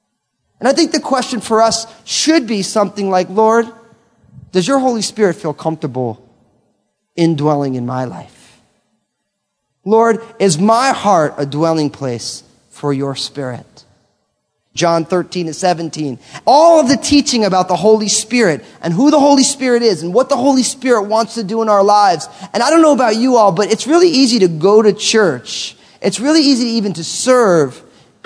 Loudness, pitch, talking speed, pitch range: -13 LUFS, 210 Hz, 175 wpm, 165-245 Hz